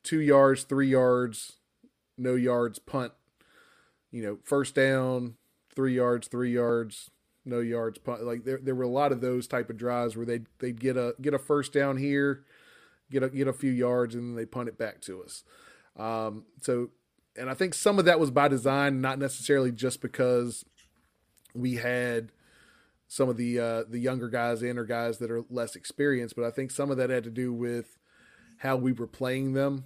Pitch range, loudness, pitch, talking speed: 120-135 Hz, -29 LUFS, 125 Hz, 200 wpm